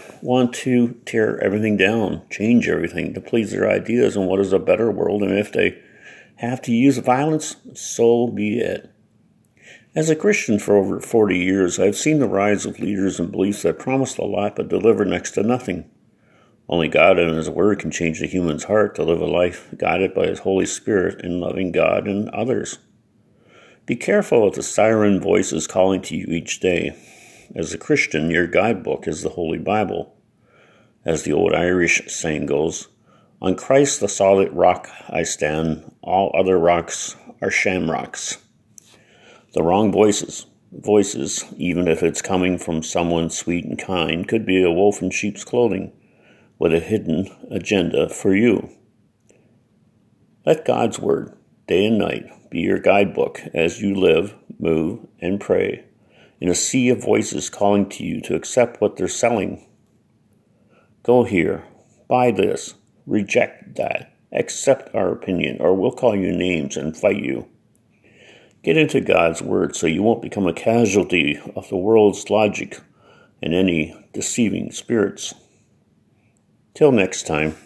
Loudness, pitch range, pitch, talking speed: -19 LUFS, 90-115 Hz, 95 Hz, 160 wpm